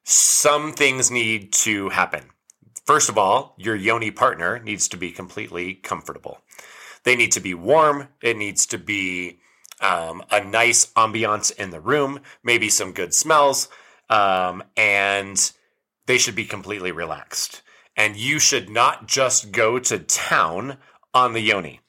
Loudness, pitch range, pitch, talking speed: -19 LUFS, 100-125 Hz, 110 Hz, 150 wpm